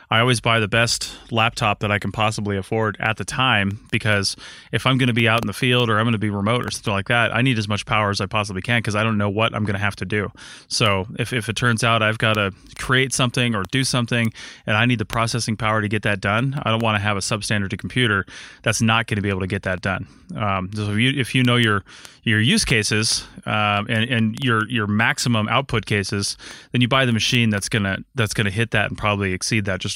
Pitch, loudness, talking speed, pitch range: 110 Hz, -20 LUFS, 260 wpm, 105-120 Hz